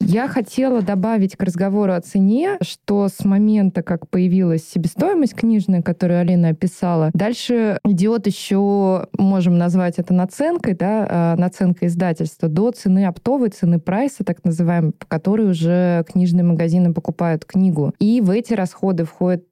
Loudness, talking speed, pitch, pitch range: -18 LUFS, 140 wpm, 185 Hz, 175-205 Hz